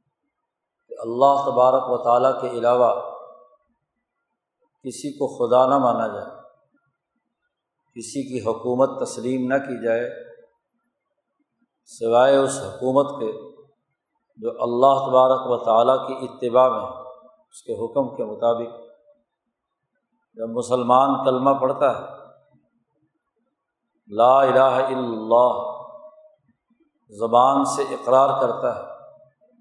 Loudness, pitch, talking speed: -20 LUFS, 135 Hz, 100 wpm